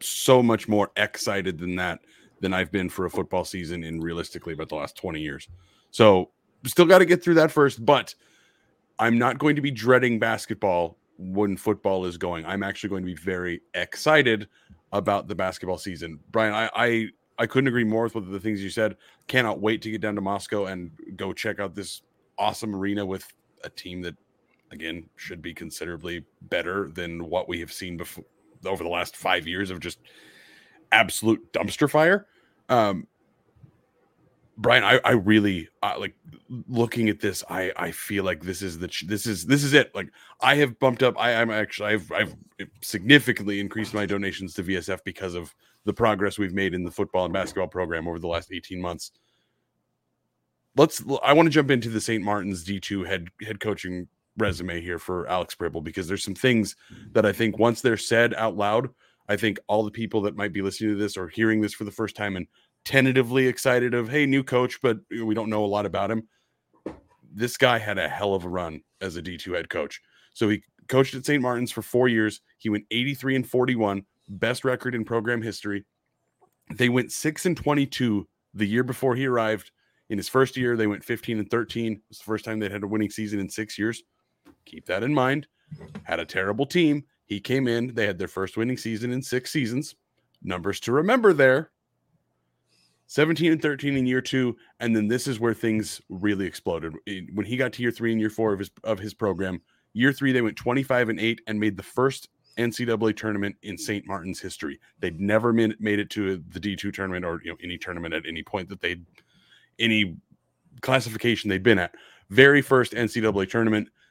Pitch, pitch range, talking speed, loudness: 110 Hz, 95-120 Hz, 200 wpm, -24 LUFS